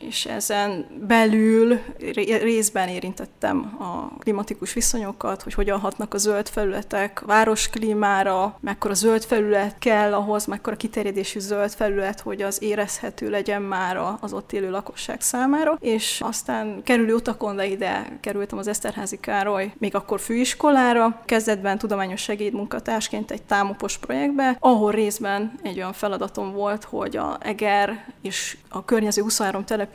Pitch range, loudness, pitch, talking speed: 200-225 Hz, -23 LUFS, 210 Hz, 135 wpm